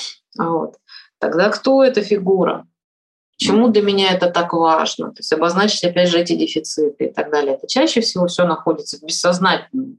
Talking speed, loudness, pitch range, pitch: 170 wpm, -17 LUFS, 160-210 Hz, 175 Hz